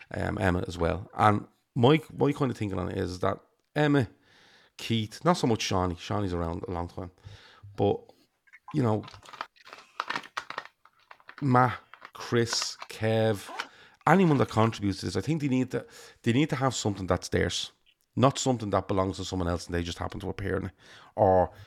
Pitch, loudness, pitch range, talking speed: 105 Hz, -28 LUFS, 95-120 Hz, 175 wpm